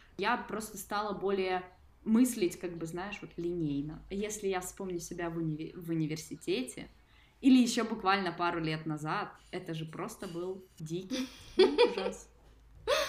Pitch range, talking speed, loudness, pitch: 170-205 Hz, 140 wpm, -33 LUFS, 185 Hz